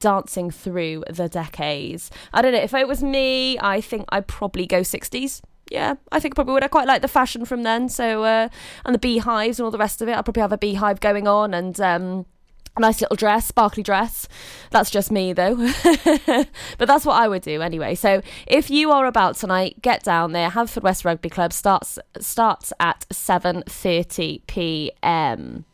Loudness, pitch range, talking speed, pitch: -20 LUFS, 185-245 Hz, 200 wpm, 215 Hz